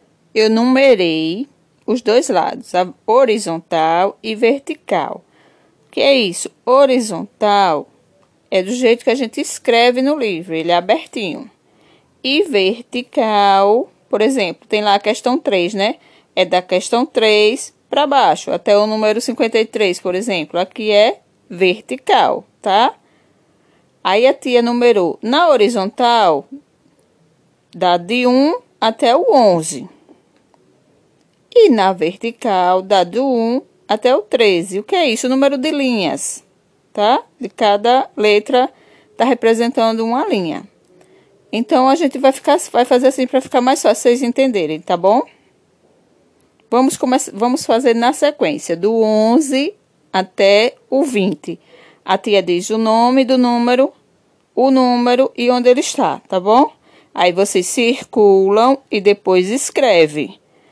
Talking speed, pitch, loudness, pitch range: 135 wpm, 235 Hz, -15 LUFS, 195-260 Hz